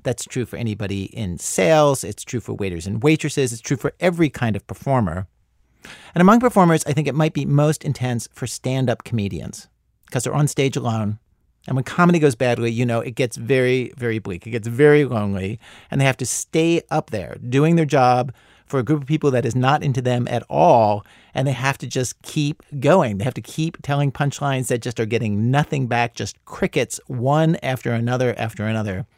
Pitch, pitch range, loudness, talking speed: 130 Hz, 115-145 Hz, -20 LUFS, 210 wpm